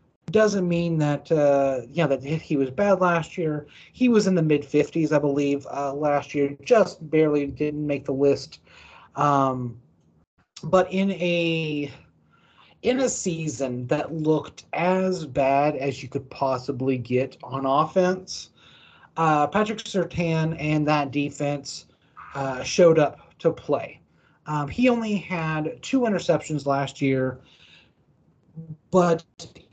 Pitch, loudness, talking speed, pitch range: 150 Hz, -24 LUFS, 135 wpm, 140-170 Hz